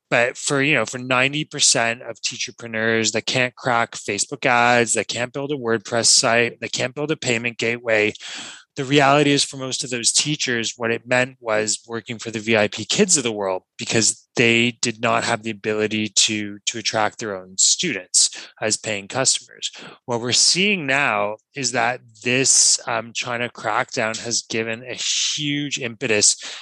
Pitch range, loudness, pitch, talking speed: 110-130 Hz, -19 LUFS, 115 Hz, 170 wpm